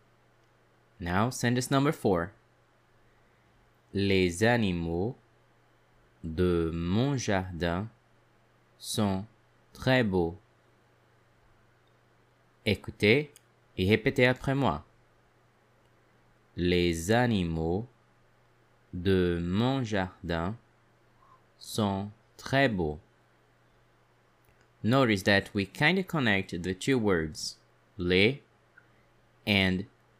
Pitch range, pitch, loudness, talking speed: 95-120 Hz, 110 Hz, -28 LUFS, 70 wpm